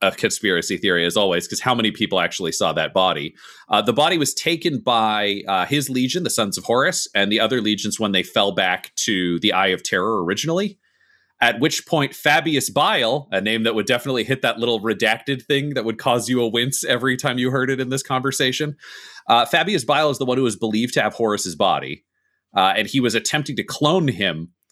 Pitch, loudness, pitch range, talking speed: 120 Hz, -19 LUFS, 105-135 Hz, 220 wpm